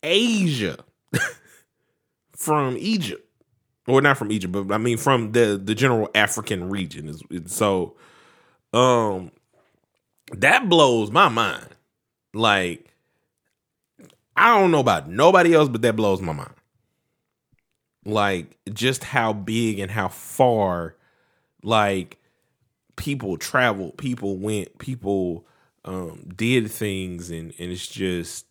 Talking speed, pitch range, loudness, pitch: 115 wpm, 95-125 Hz, -21 LUFS, 105 Hz